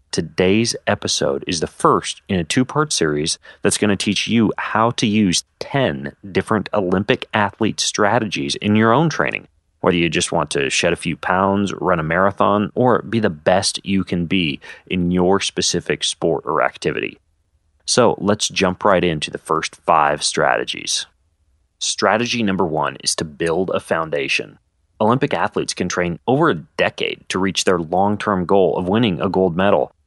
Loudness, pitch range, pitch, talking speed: -18 LUFS, 80-105 Hz, 95 Hz, 175 wpm